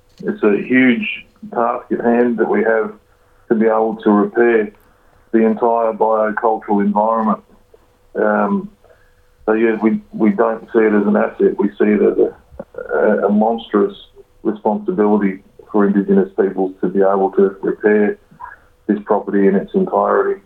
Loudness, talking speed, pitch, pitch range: -16 LUFS, 150 wpm, 110 Hz, 100-115 Hz